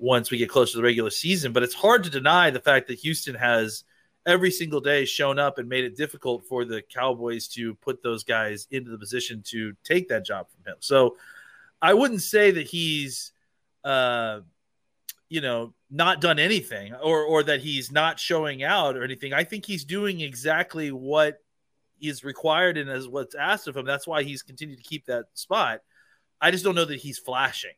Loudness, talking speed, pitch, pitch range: -24 LUFS, 200 wpm, 140 Hz, 125-160 Hz